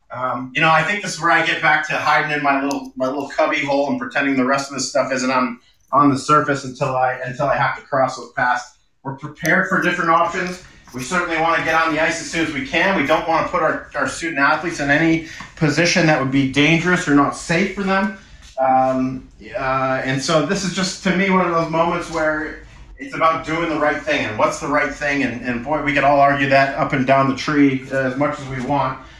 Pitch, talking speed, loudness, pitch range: 150 Hz, 255 wpm, -18 LUFS, 135-165 Hz